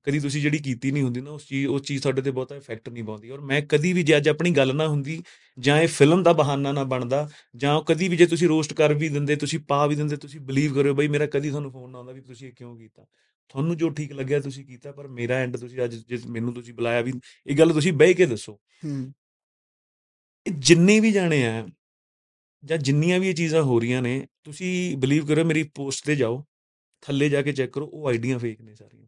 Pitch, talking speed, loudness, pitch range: 140 Hz, 235 wpm, -23 LUFS, 130-155 Hz